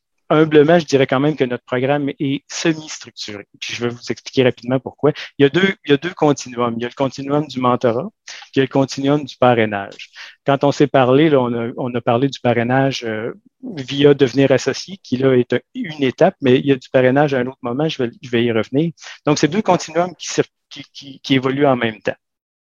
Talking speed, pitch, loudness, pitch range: 235 wpm, 135 Hz, -17 LUFS, 125-145 Hz